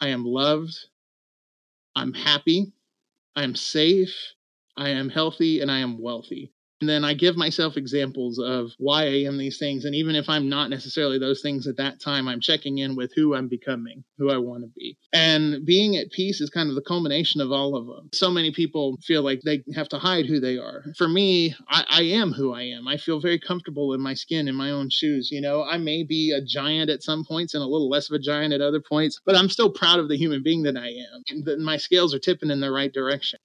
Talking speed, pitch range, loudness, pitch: 240 wpm, 135-160 Hz, -23 LUFS, 150 Hz